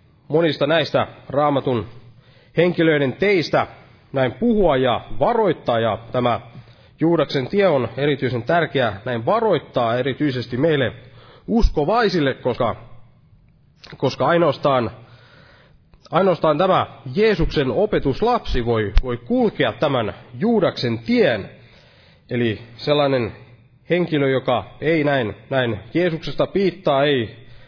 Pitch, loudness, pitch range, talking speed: 130 Hz, -20 LUFS, 120-155 Hz, 95 wpm